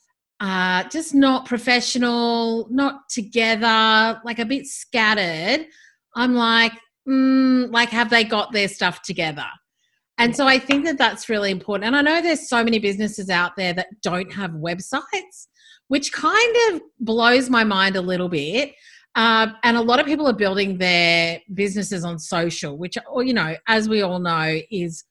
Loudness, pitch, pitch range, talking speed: -19 LUFS, 230 Hz, 190-260 Hz, 165 wpm